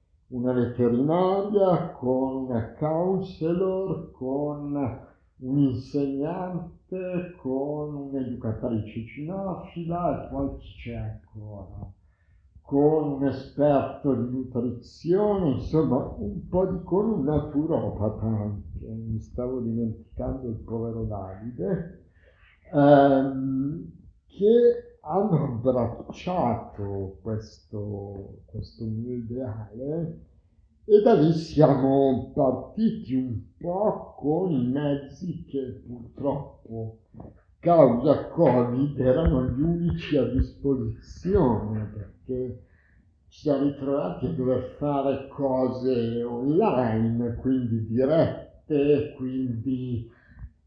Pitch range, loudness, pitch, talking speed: 115-150 Hz, -26 LUFS, 130 Hz, 85 wpm